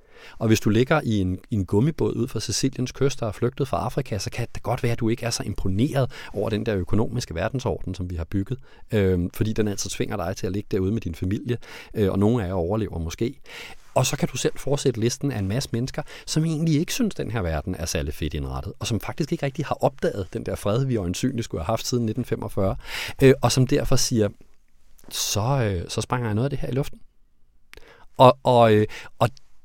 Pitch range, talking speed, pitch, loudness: 100-130 Hz, 235 wpm, 115 Hz, -24 LUFS